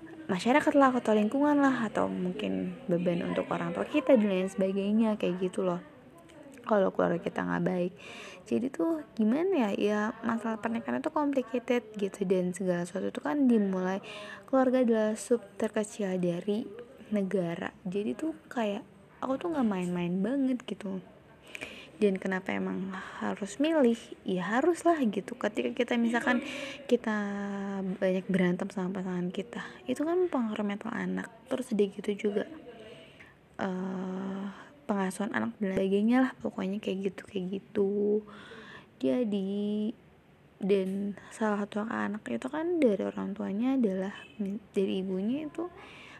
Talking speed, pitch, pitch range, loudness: 135 wpm, 205 Hz, 190-245 Hz, -31 LUFS